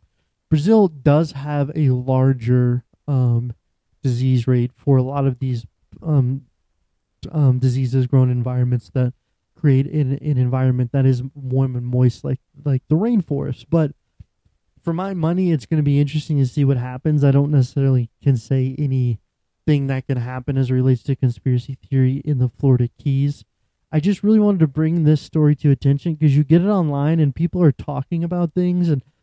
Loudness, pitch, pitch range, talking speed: -19 LUFS, 135 Hz, 125-150 Hz, 180 wpm